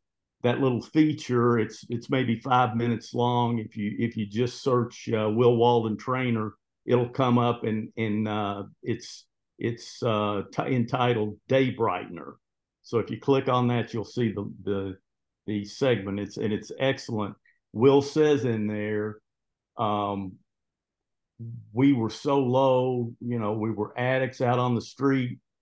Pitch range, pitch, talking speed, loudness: 105-125 Hz, 115 Hz, 155 wpm, -26 LUFS